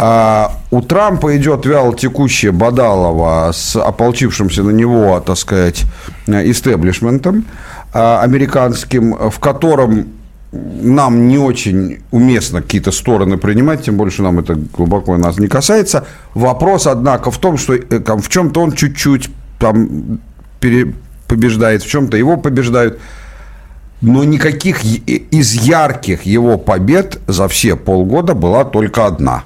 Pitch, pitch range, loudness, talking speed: 115 Hz, 100-135 Hz, -12 LUFS, 120 wpm